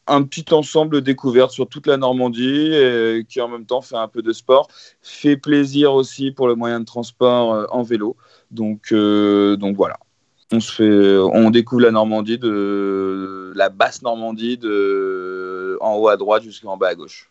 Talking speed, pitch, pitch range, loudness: 180 wpm, 115 Hz, 105-130 Hz, -17 LUFS